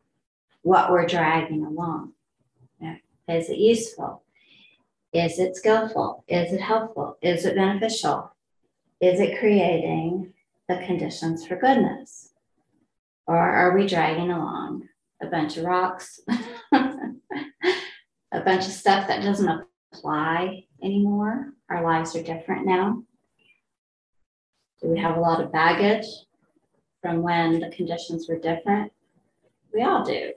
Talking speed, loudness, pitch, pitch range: 125 wpm, -24 LUFS, 180 Hz, 165-215 Hz